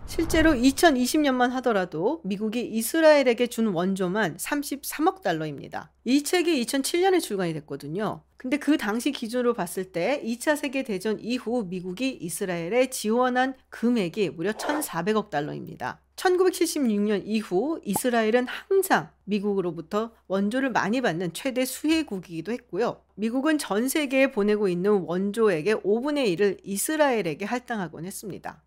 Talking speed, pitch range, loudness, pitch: 310 characters per minute, 195-275 Hz, -25 LUFS, 230 Hz